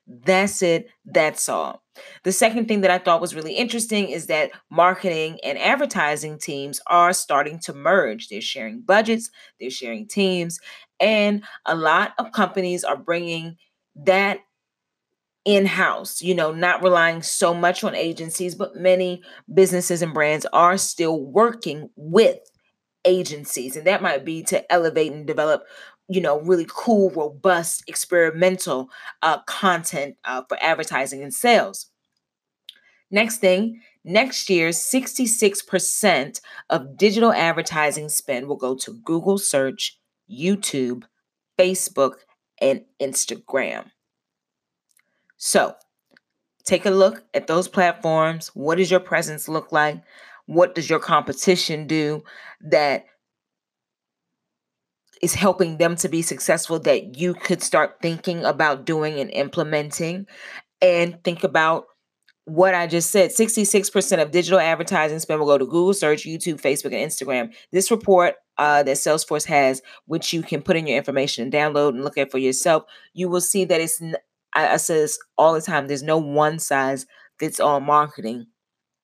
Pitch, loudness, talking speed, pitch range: 170 Hz, -20 LUFS, 145 wpm, 150-190 Hz